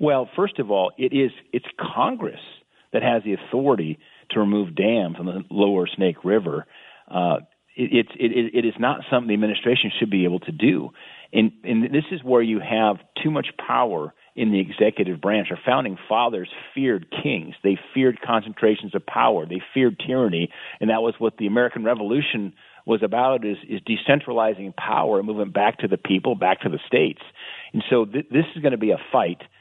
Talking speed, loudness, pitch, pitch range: 195 wpm, -22 LUFS, 110 Hz, 100-125 Hz